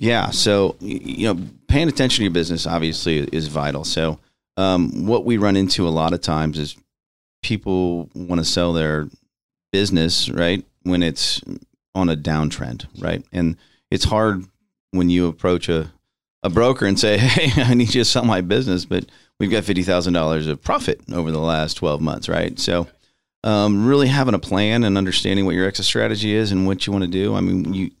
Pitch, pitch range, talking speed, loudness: 90 Hz, 80-105 Hz, 190 wpm, -19 LUFS